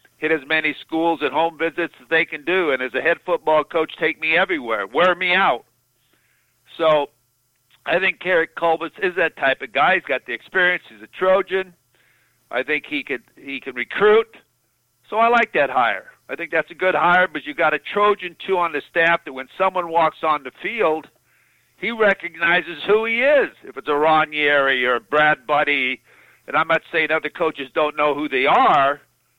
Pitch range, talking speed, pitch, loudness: 150-180 Hz, 200 wpm, 165 Hz, -19 LUFS